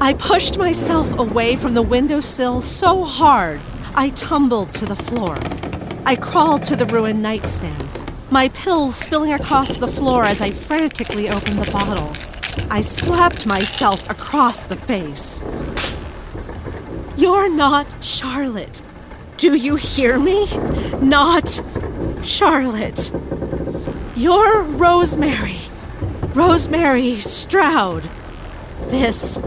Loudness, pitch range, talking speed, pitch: -15 LUFS, 235-330 Hz, 105 wpm, 280 Hz